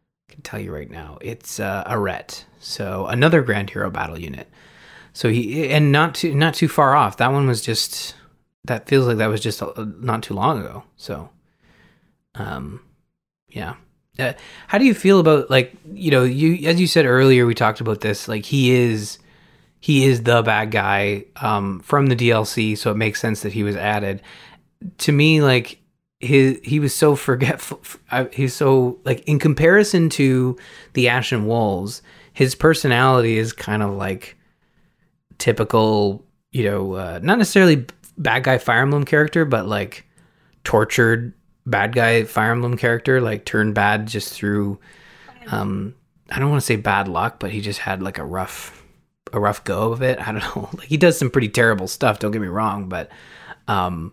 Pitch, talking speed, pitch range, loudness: 120 Hz, 180 wpm, 105-140 Hz, -18 LUFS